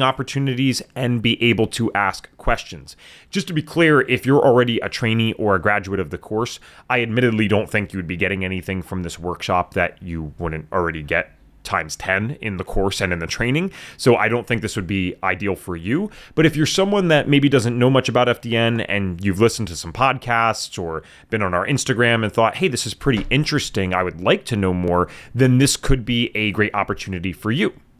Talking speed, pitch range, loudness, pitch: 215 wpm, 95-130 Hz, -20 LUFS, 115 Hz